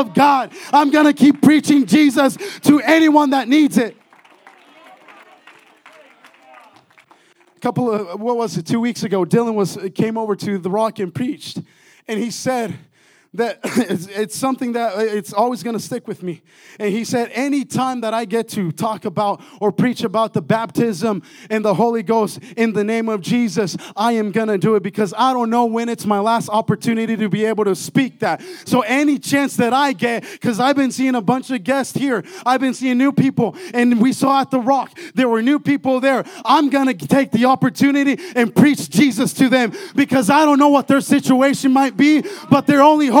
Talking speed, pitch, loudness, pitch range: 195 wpm, 240 Hz, -17 LUFS, 220-275 Hz